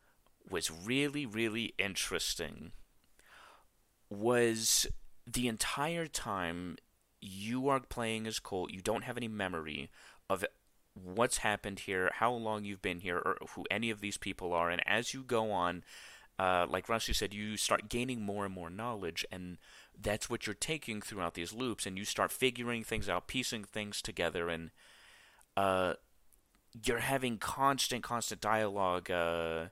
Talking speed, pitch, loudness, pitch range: 150 wpm, 110 Hz, -35 LUFS, 95-120 Hz